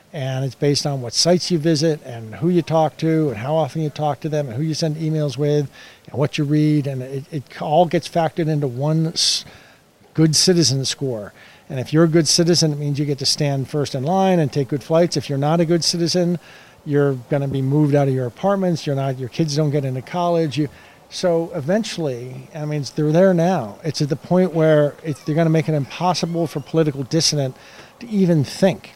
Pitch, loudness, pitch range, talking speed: 150 Hz, -19 LUFS, 140-165 Hz, 225 wpm